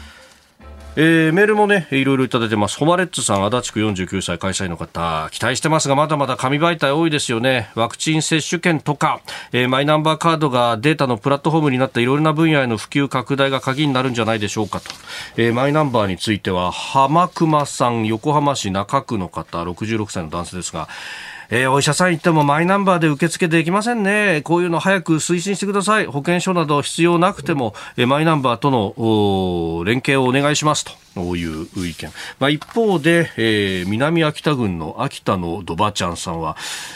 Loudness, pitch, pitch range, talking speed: -18 LUFS, 135 Hz, 105-160 Hz, 410 characters per minute